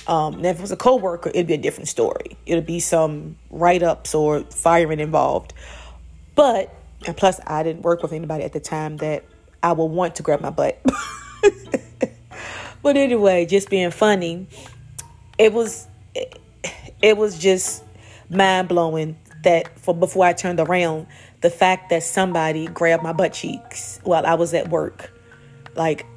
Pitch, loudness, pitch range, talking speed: 170 Hz, -20 LUFS, 155-185 Hz, 160 wpm